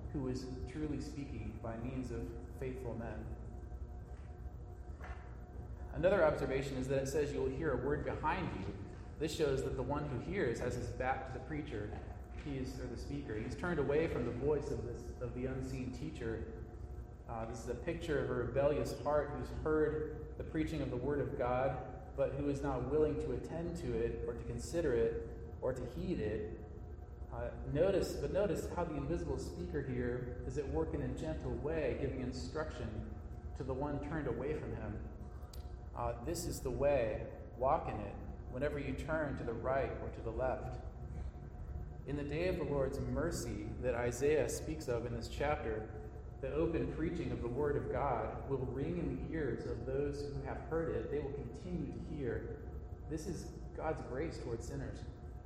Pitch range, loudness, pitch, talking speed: 110-145 Hz, -39 LUFS, 125 Hz, 190 wpm